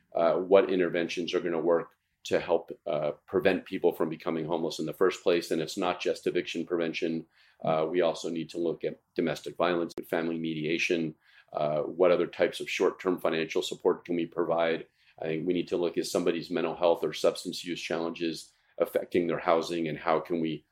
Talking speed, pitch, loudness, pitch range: 205 wpm, 80 Hz, -29 LUFS, 80-85 Hz